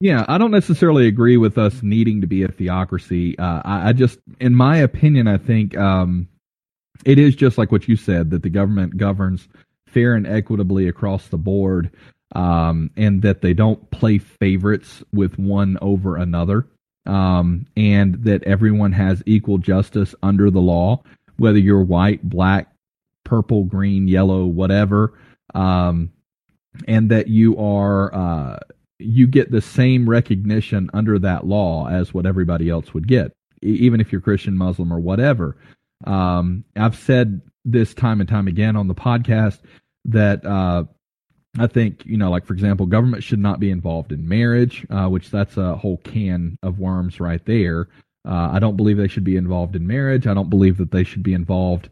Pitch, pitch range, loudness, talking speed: 100 Hz, 95-110 Hz, -17 LUFS, 175 wpm